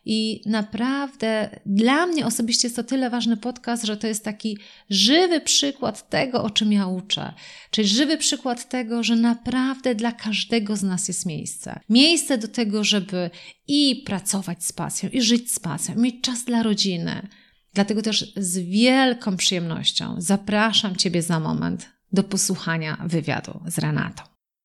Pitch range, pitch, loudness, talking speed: 195-240 Hz, 215 Hz, -22 LUFS, 155 wpm